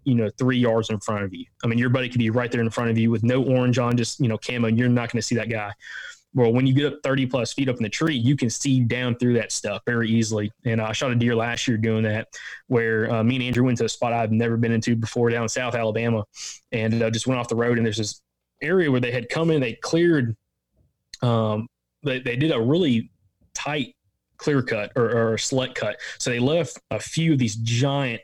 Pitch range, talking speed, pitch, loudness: 115-130 Hz, 265 wpm, 120 Hz, -23 LUFS